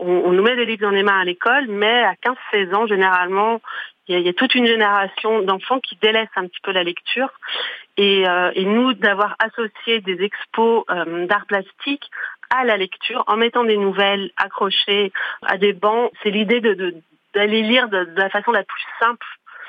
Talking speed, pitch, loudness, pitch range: 205 wpm, 205 Hz, -18 LUFS, 195-230 Hz